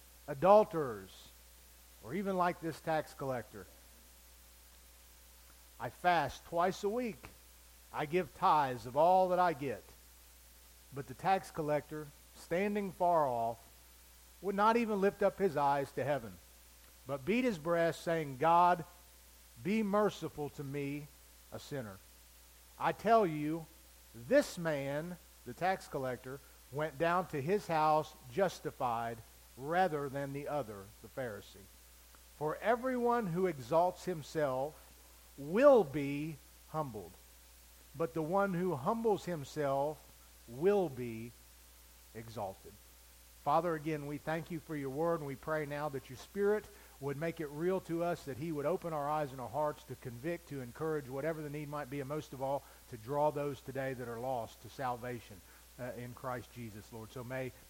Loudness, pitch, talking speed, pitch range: -35 LUFS, 145 Hz, 150 wpm, 105-165 Hz